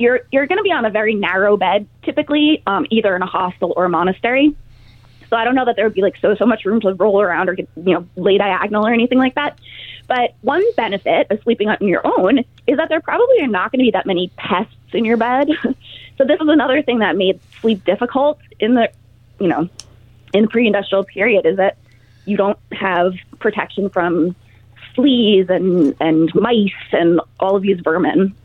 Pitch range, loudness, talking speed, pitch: 180-250 Hz, -16 LUFS, 215 wpm, 205 Hz